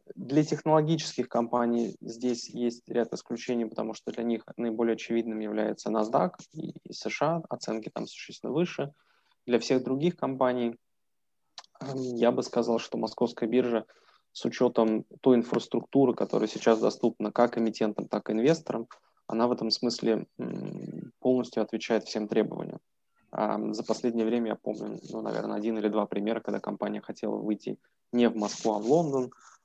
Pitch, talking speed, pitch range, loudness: 115 Hz, 145 wpm, 110-125 Hz, -29 LUFS